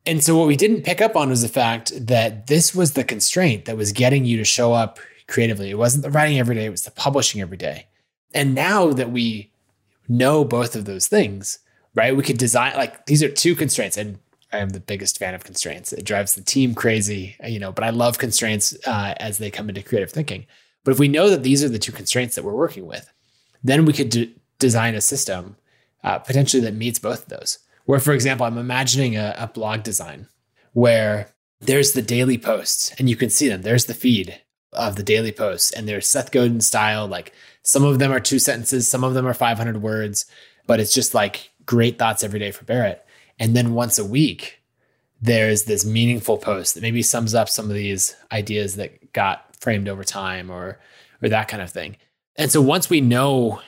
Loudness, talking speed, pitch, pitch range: -19 LUFS, 220 wpm, 115 Hz, 105-135 Hz